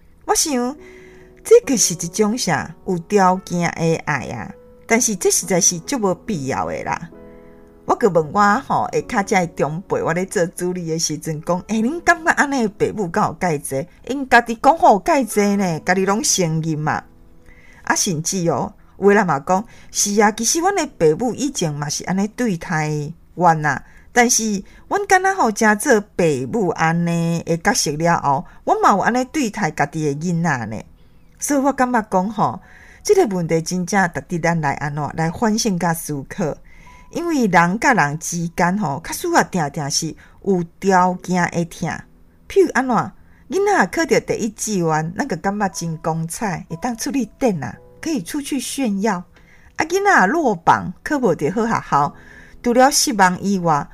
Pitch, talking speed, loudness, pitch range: 190 Hz, 255 characters per minute, -18 LUFS, 165-240 Hz